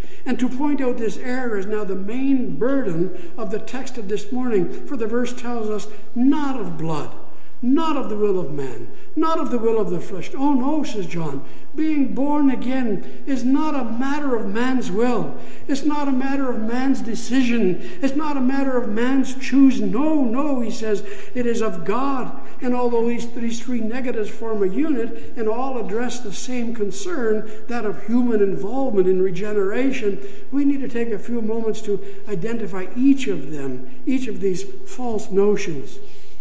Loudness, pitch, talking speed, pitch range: -23 LUFS, 235 Hz, 185 wpm, 210-265 Hz